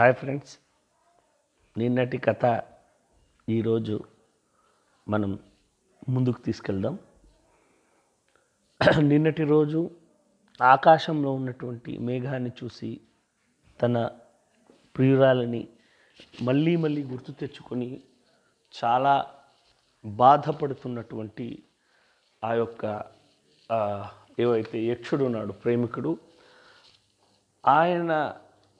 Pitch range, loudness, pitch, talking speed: 115-145 Hz, -25 LUFS, 125 Hz, 60 wpm